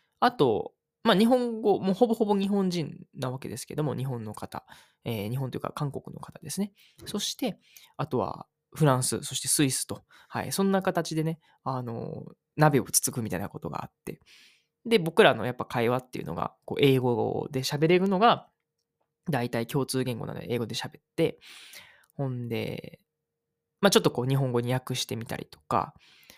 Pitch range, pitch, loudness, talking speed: 130-185 Hz, 150 Hz, -28 LUFS, 330 characters per minute